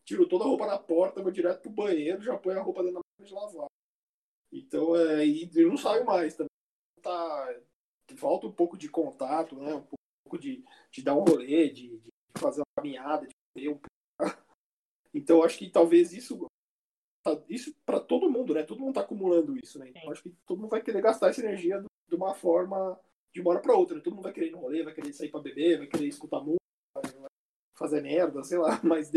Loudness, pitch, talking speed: -29 LUFS, 185 Hz, 210 wpm